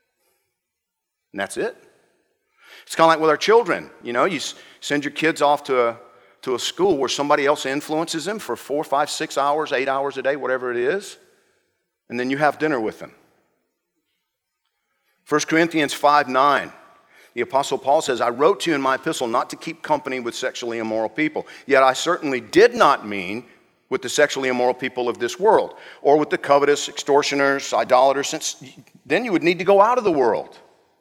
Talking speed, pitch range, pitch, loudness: 195 wpm, 135-170 Hz, 145 Hz, -20 LUFS